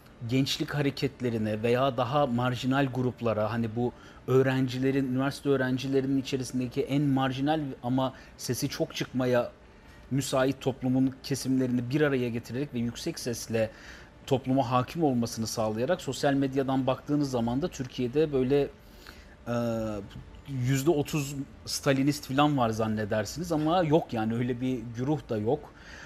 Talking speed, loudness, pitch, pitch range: 120 wpm, -29 LUFS, 130 Hz, 120-140 Hz